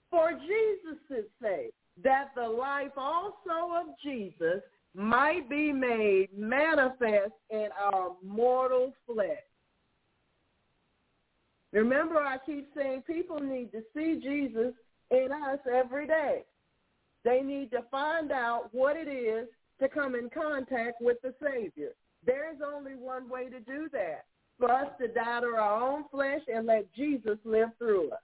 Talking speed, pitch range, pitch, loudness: 140 wpm, 235-300 Hz, 270 Hz, -31 LUFS